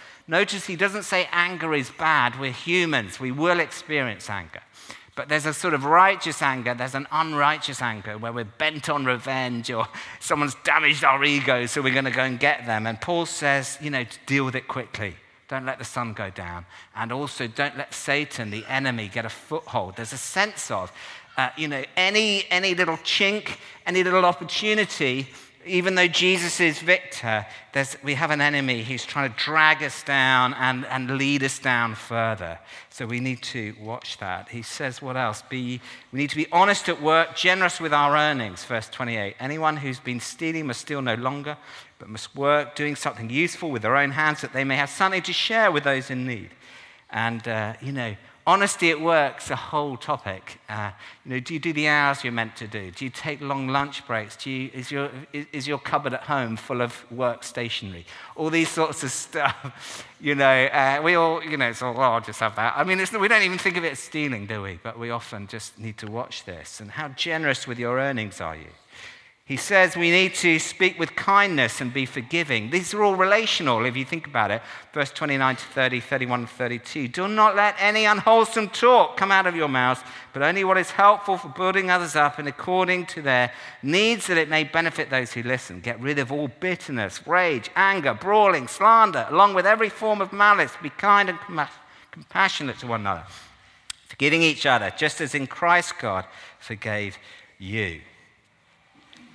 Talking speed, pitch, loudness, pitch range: 205 wpm, 140 Hz, -23 LUFS, 120-170 Hz